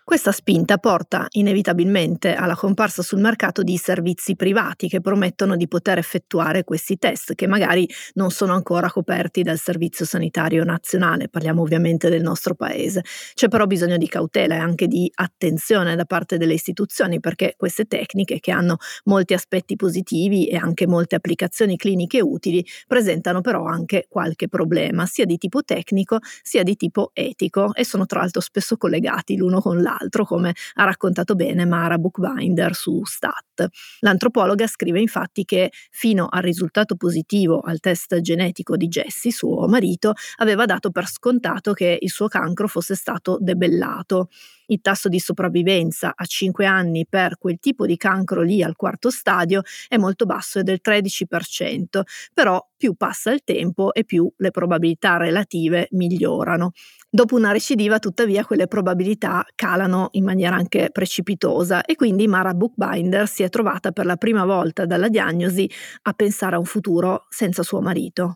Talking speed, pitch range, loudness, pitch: 160 wpm, 175-205 Hz, -20 LUFS, 185 Hz